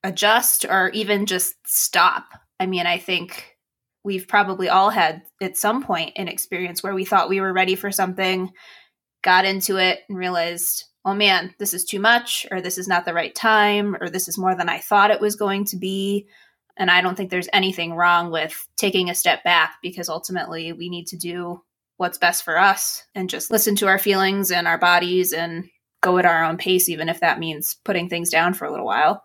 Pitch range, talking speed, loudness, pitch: 175-195 Hz, 220 wpm, -20 LUFS, 185 Hz